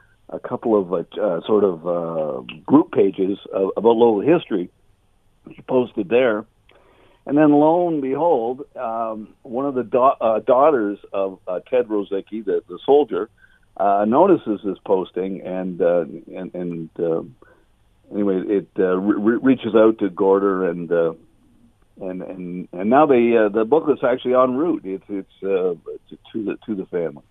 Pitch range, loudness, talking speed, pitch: 95-130 Hz, -19 LUFS, 165 wpm, 100 Hz